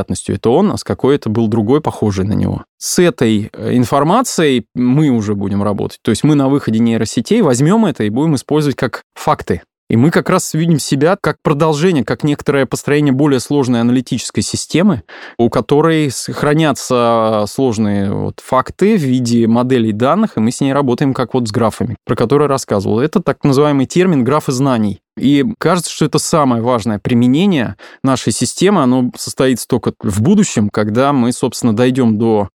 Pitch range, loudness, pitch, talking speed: 115-150 Hz, -14 LUFS, 130 Hz, 170 wpm